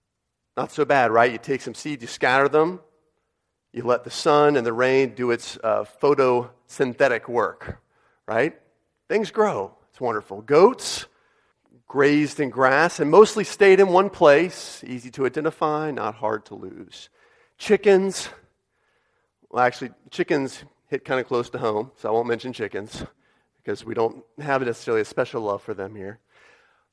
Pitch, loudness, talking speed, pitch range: 135 Hz, -21 LUFS, 160 wpm, 120-155 Hz